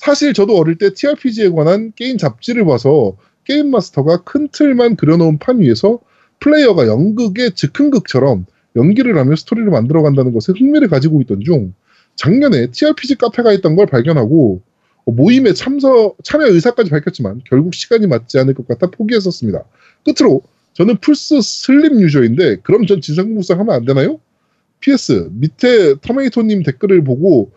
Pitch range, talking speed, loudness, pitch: 150-255 Hz, 365 characters per minute, -12 LUFS, 200 Hz